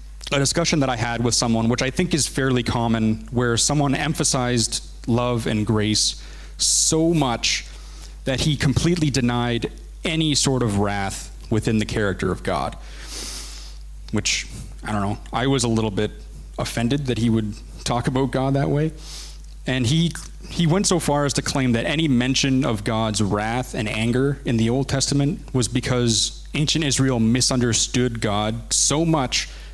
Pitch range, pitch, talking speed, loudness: 110-140 Hz, 120 Hz, 165 wpm, -21 LUFS